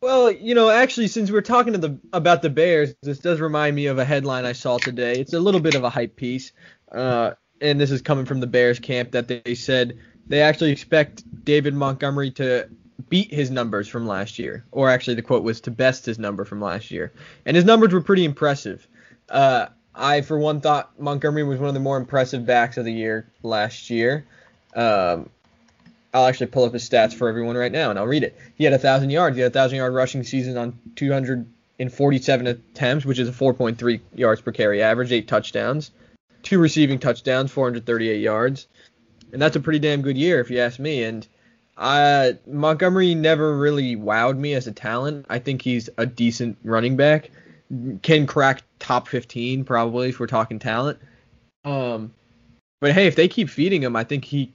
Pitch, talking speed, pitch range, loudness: 130 Hz, 200 wpm, 120-150 Hz, -21 LUFS